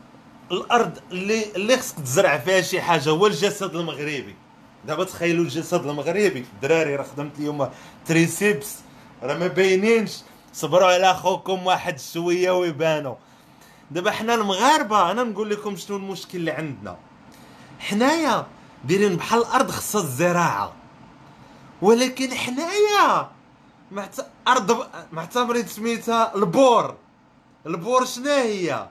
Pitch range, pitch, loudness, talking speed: 165-230 Hz, 185 Hz, -21 LUFS, 110 wpm